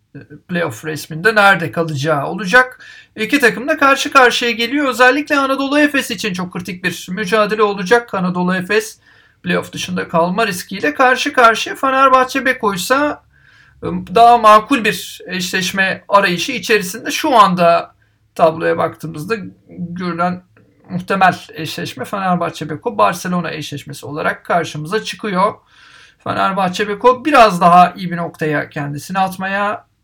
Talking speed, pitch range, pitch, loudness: 120 wpm, 170-235 Hz, 195 Hz, -15 LUFS